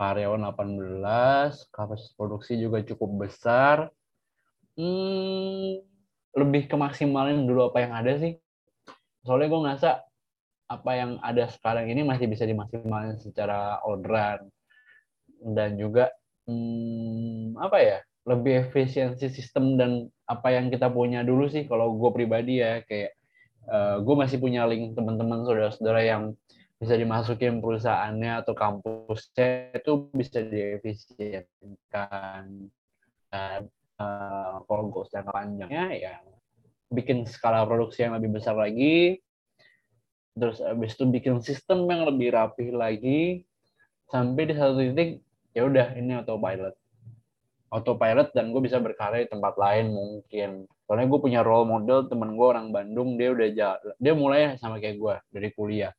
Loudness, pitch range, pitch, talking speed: -26 LUFS, 105-130 Hz, 115 Hz, 130 wpm